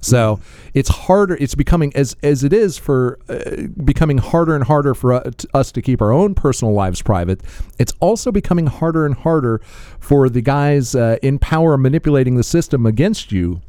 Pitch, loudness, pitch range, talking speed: 140 Hz, -16 LUFS, 120-155 Hz, 190 wpm